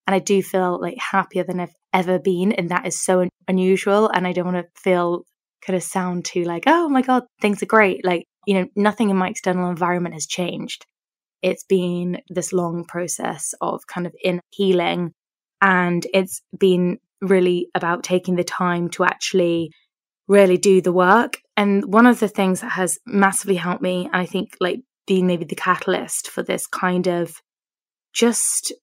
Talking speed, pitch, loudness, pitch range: 185 wpm, 185 Hz, -20 LUFS, 180-195 Hz